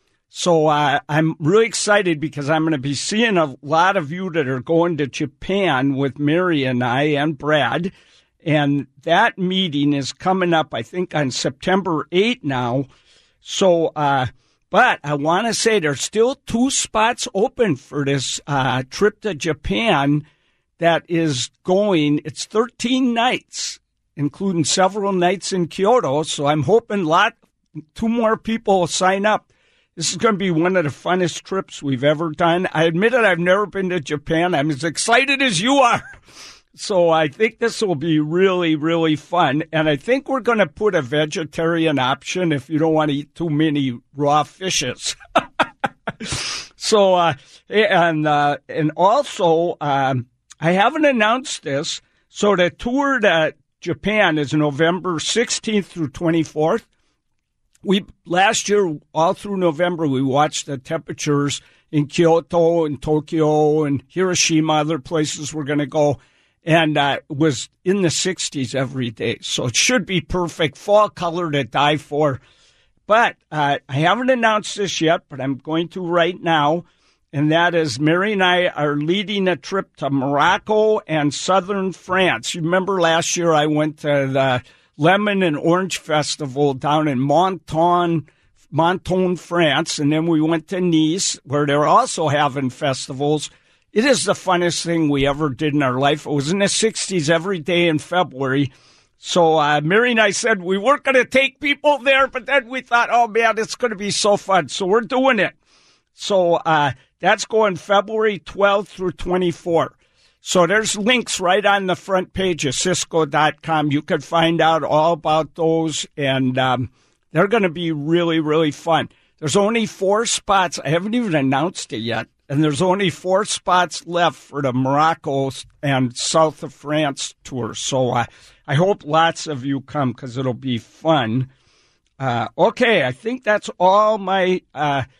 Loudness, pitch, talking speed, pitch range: -18 LUFS, 165 Hz, 165 wpm, 145-190 Hz